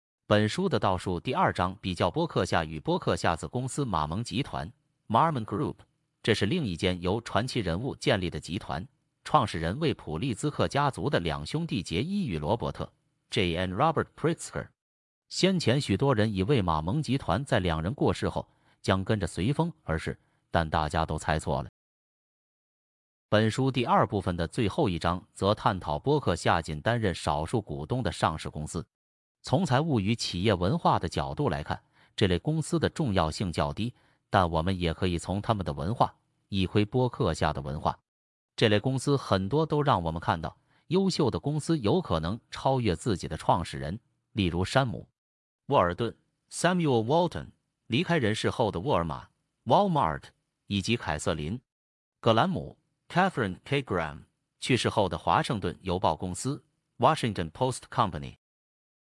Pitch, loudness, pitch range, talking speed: 105 Hz, -28 LUFS, 85-135 Hz, 315 characters per minute